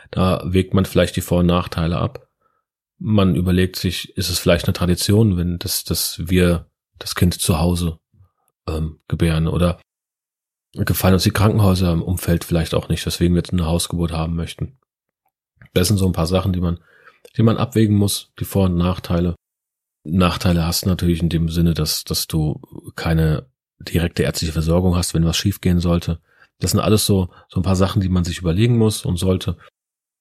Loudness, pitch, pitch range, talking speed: -19 LUFS, 90 Hz, 85-95 Hz, 185 wpm